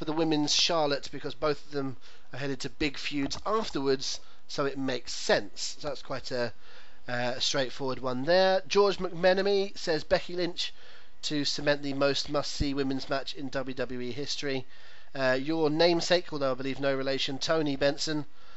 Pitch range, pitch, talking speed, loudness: 135-165 Hz, 140 Hz, 170 wpm, -29 LUFS